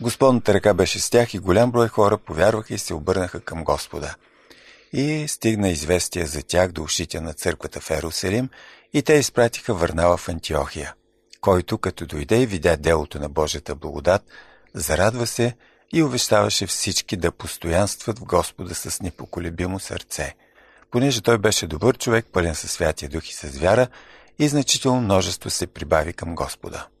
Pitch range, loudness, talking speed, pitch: 80-120 Hz, -22 LUFS, 160 wpm, 95 Hz